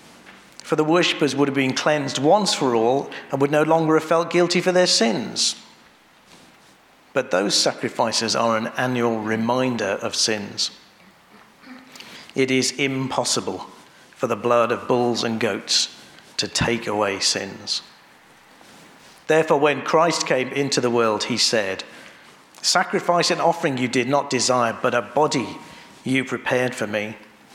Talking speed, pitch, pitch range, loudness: 145 wpm, 130 Hz, 120-155 Hz, -21 LUFS